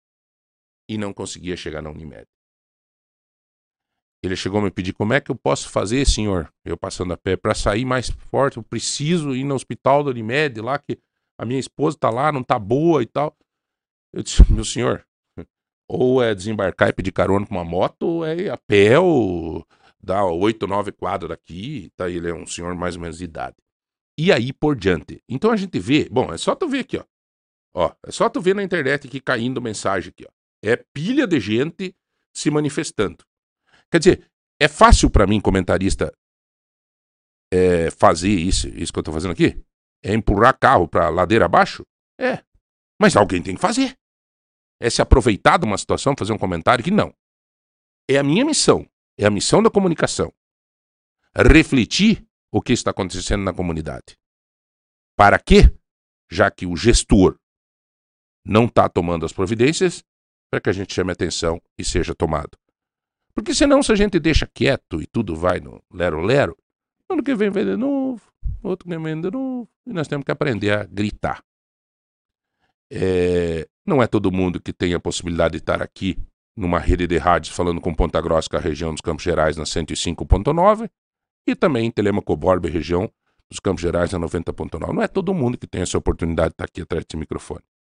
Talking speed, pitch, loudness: 185 wpm, 105 Hz, -20 LUFS